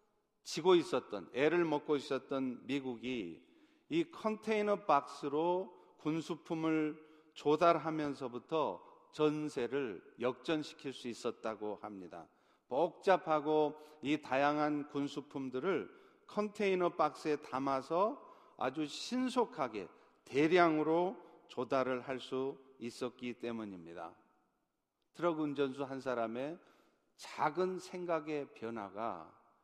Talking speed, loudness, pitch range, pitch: 225 characters per minute, -36 LUFS, 130-170 Hz, 150 Hz